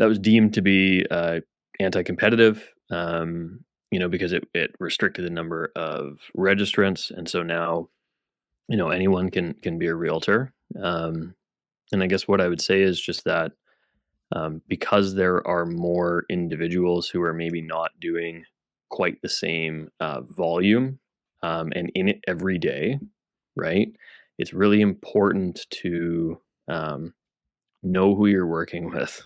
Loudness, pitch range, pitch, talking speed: -24 LUFS, 85-95 Hz, 85 Hz, 150 wpm